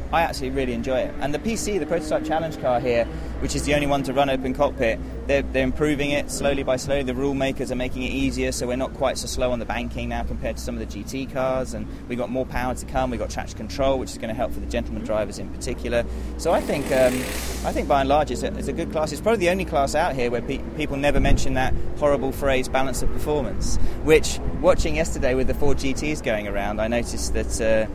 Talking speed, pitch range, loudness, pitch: 260 wpm, 120-140 Hz, -24 LUFS, 130 Hz